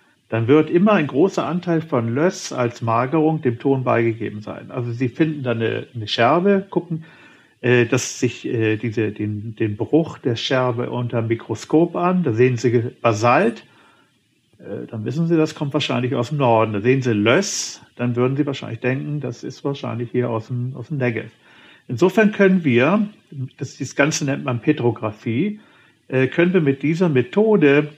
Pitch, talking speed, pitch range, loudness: 130 Hz, 170 wpm, 120-155 Hz, -20 LUFS